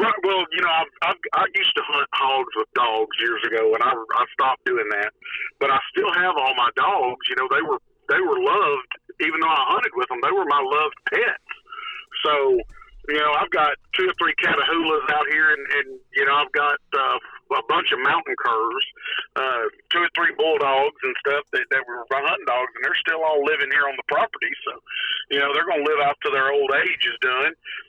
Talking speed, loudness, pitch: 225 wpm, -21 LUFS, 390 Hz